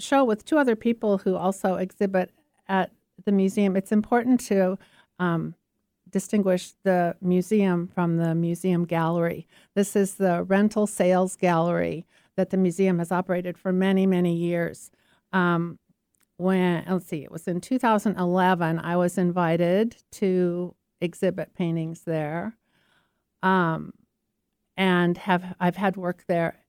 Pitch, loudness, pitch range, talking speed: 185 Hz, -25 LUFS, 175-195 Hz, 135 wpm